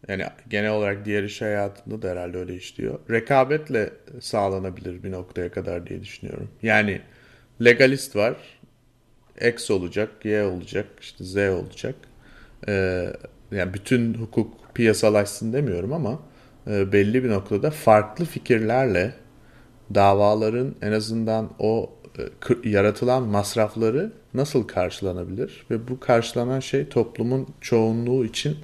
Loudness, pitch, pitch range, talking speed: -23 LUFS, 110 Hz, 100-125 Hz, 110 wpm